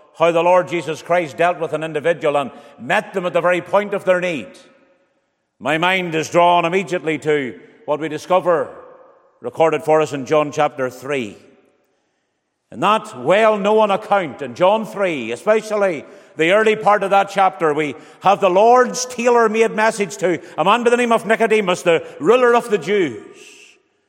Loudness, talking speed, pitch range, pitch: -17 LUFS, 175 wpm, 160-215 Hz, 185 Hz